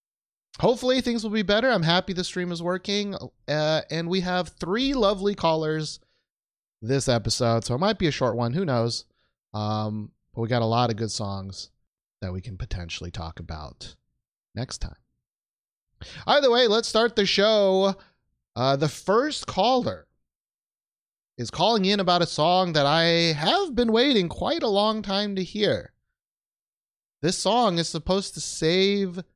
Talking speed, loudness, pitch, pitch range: 160 wpm, -24 LUFS, 170 Hz, 120-200 Hz